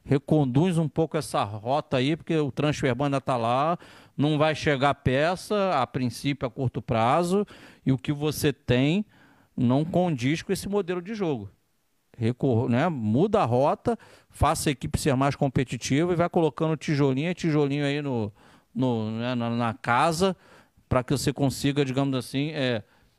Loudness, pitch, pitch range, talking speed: -26 LUFS, 140 Hz, 130-160 Hz, 160 wpm